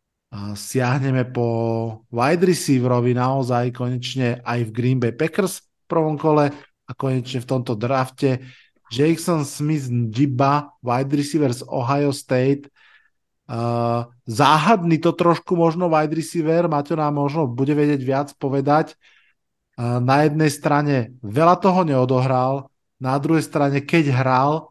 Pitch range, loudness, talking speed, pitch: 125-155 Hz, -20 LUFS, 130 wpm, 140 Hz